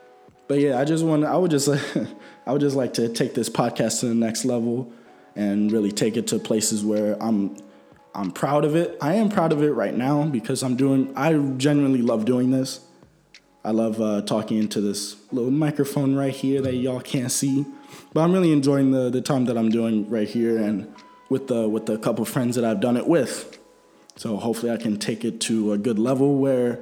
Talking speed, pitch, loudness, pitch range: 210 wpm, 125 Hz, -22 LUFS, 110-140 Hz